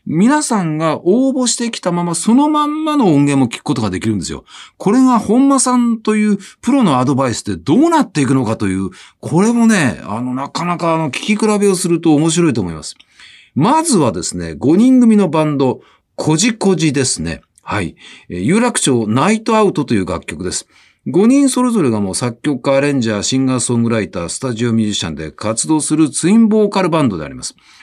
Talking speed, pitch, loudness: 405 characters per minute, 160 Hz, -14 LUFS